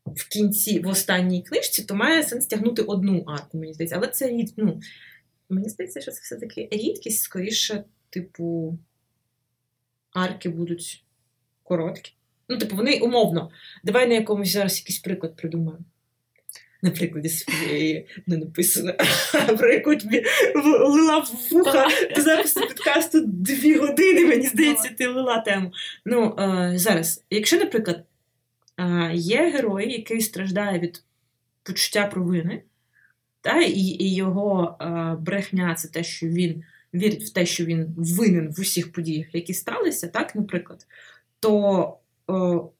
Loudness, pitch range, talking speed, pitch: -22 LUFS, 165-220 Hz, 130 wpm, 185 Hz